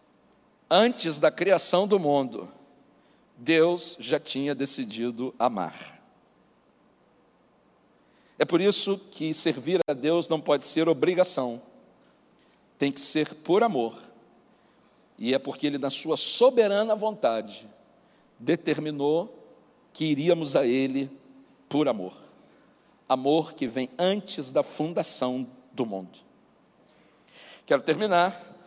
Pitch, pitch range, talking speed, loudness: 155 Hz, 135-175 Hz, 105 wpm, -25 LUFS